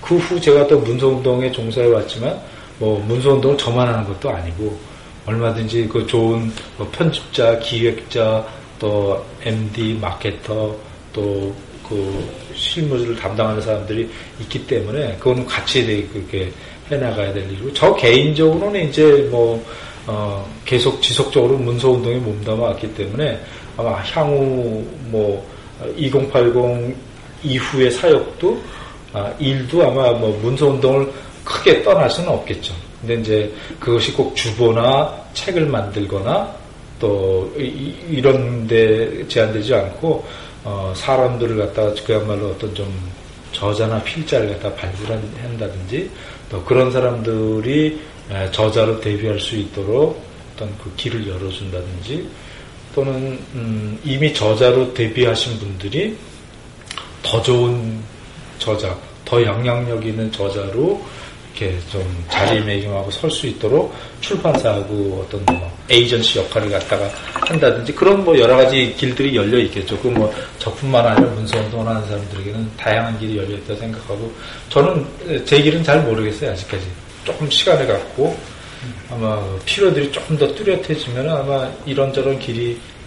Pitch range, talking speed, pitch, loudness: 105-130 Hz, 280 characters per minute, 115 Hz, -18 LUFS